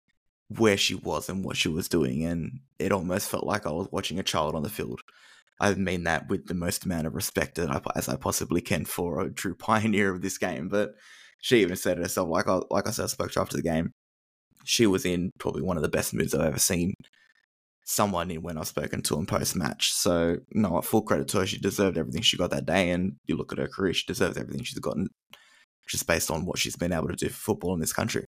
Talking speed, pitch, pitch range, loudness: 255 wpm, 90 Hz, 80-100 Hz, -27 LUFS